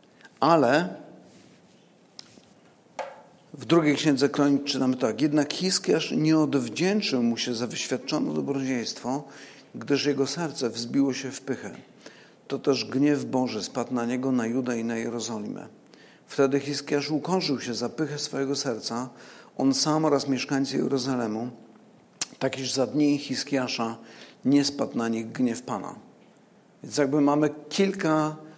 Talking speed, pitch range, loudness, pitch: 130 wpm, 125-150 Hz, -26 LUFS, 140 Hz